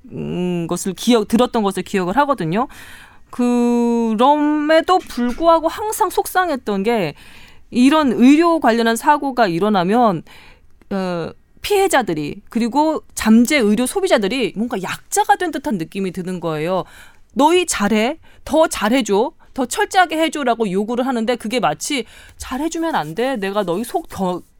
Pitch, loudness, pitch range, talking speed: 245 Hz, -17 LUFS, 205-305 Hz, 290 characters per minute